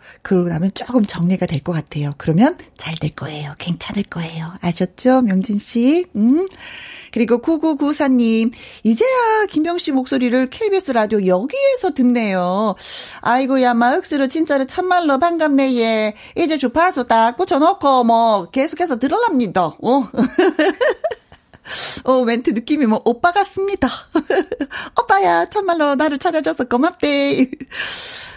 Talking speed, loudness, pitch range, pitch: 275 characters per minute, -17 LUFS, 220-325 Hz, 260 Hz